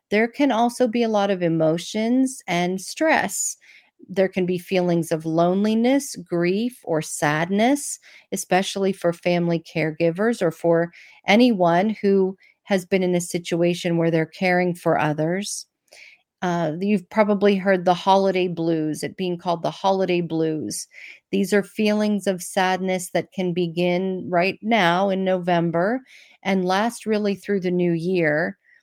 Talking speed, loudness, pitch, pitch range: 145 wpm, -22 LUFS, 185 Hz, 170-205 Hz